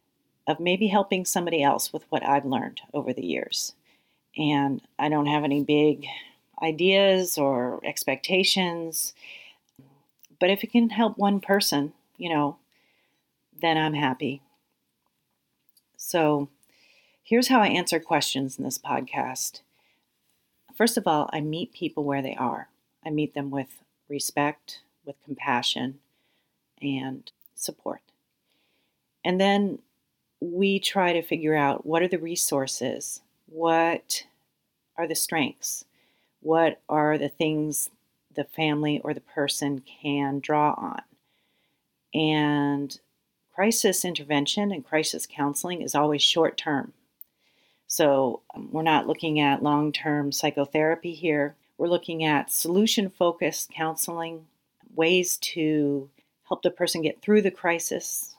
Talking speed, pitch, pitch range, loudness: 125 wpm, 155 Hz, 145-180 Hz, -25 LUFS